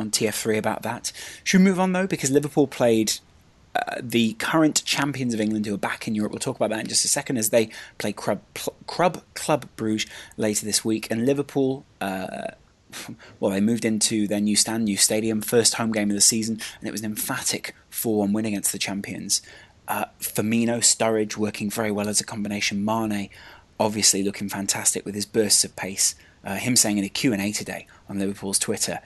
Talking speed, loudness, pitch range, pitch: 200 wpm, -23 LUFS, 100-115 Hz, 110 Hz